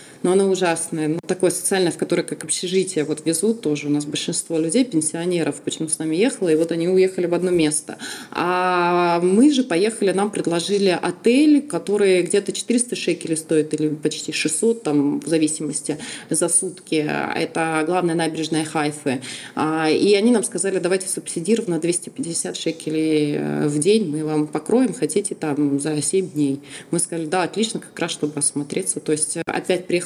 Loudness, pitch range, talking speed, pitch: -20 LUFS, 155-185 Hz, 165 wpm, 165 Hz